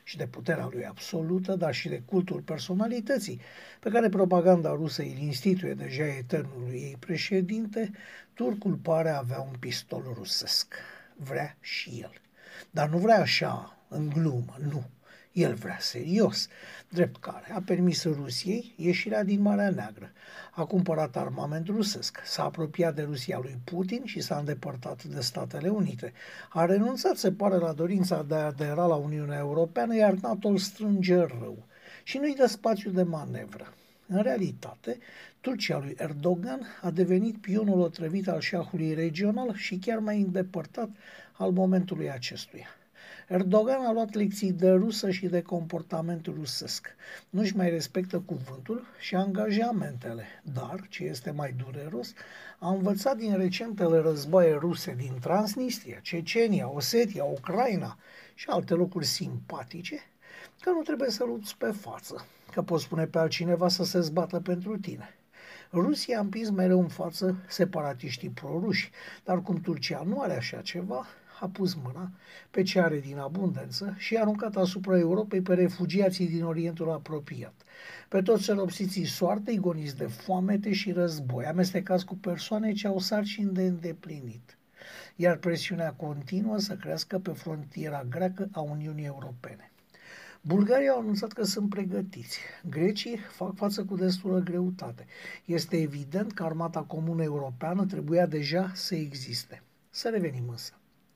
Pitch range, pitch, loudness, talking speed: 160-200 Hz, 180 Hz, -29 LUFS, 145 wpm